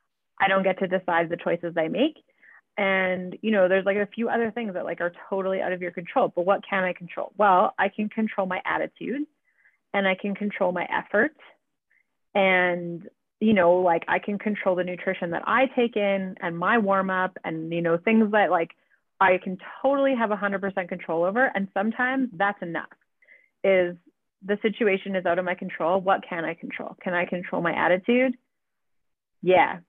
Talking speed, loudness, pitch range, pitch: 190 wpm, -24 LUFS, 180-215 Hz, 190 Hz